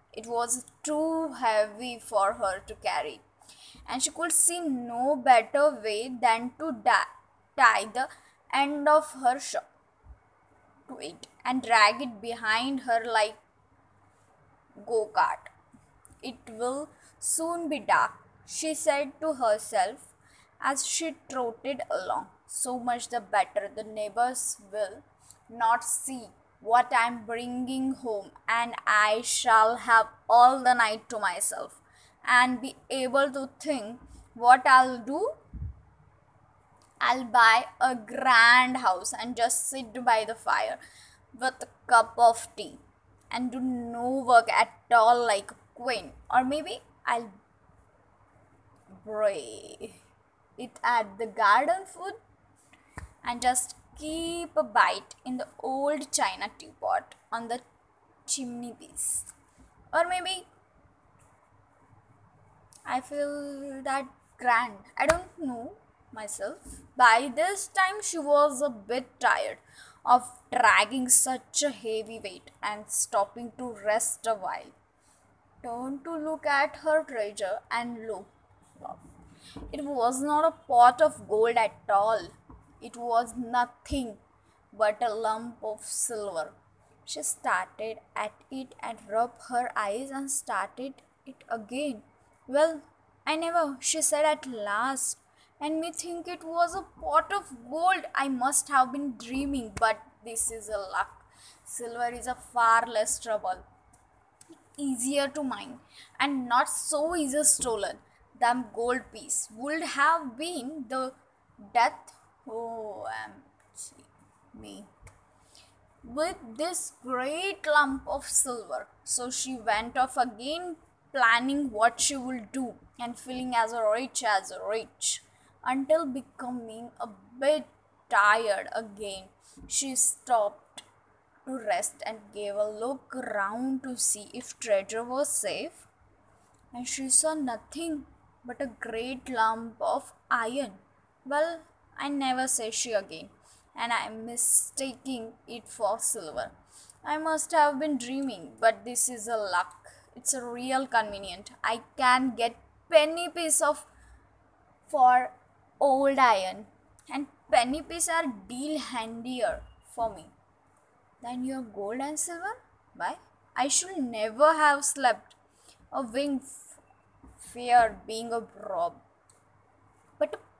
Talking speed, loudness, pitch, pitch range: 125 wpm, -27 LUFS, 250 Hz, 230-290 Hz